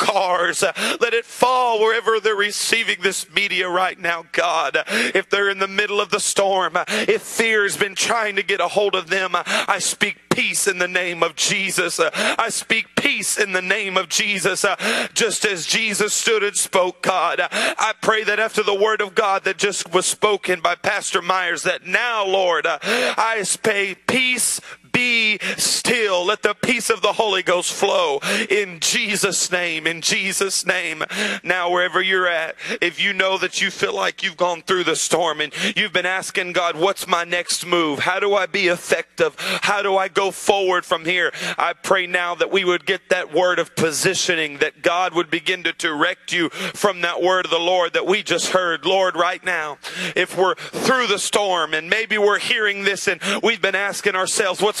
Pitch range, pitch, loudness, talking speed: 180-205 Hz, 190 Hz, -19 LUFS, 190 wpm